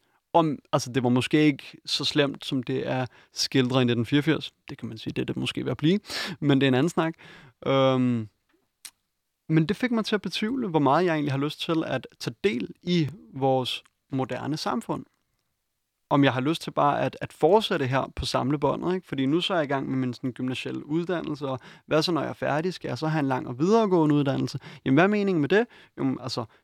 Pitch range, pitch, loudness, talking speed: 130-170 Hz, 145 Hz, -26 LUFS, 230 wpm